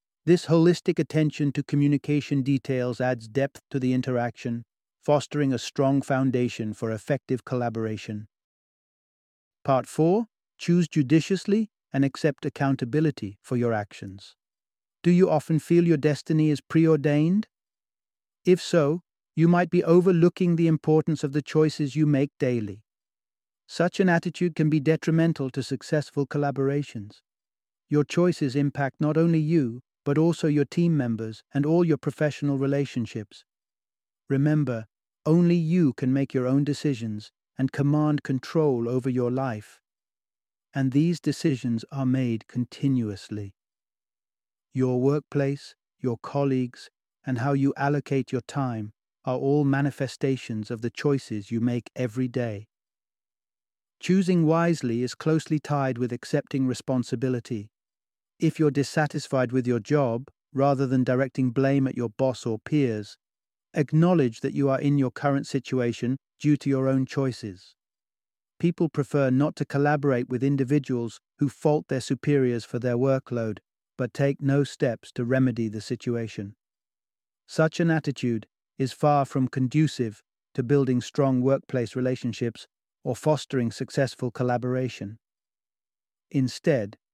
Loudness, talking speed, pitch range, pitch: -25 LUFS, 130 wpm, 120-150 Hz, 135 Hz